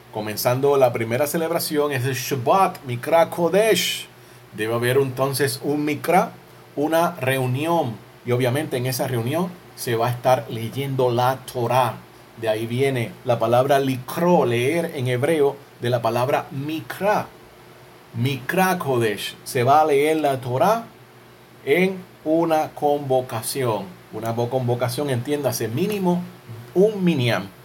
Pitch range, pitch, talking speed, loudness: 120-160 Hz, 135 Hz, 125 wpm, -21 LUFS